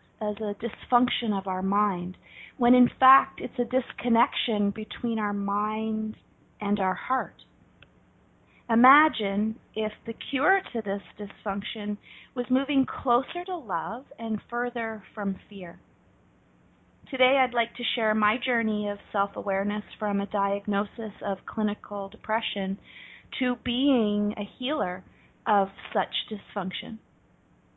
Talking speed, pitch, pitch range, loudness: 125 wpm, 215 Hz, 205-245 Hz, -27 LUFS